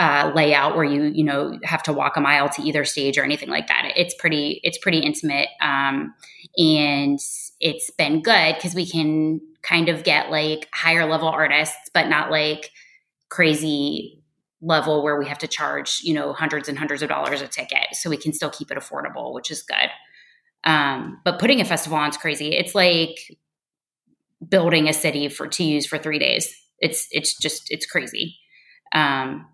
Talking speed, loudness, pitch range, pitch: 185 wpm, -20 LUFS, 150-165 Hz, 155 Hz